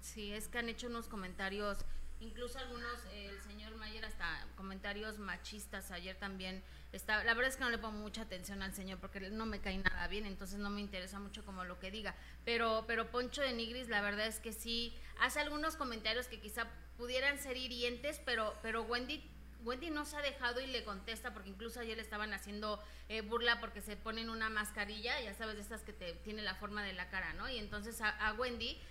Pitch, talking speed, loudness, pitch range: 220 Hz, 215 wpm, -41 LUFS, 205-235 Hz